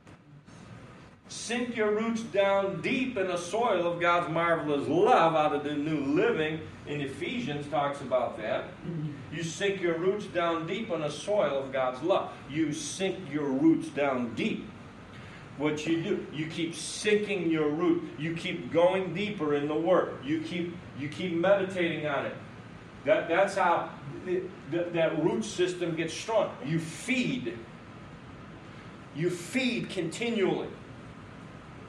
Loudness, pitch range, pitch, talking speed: -29 LUFS, 150-190 Hz, 170 Hz, 145 wpm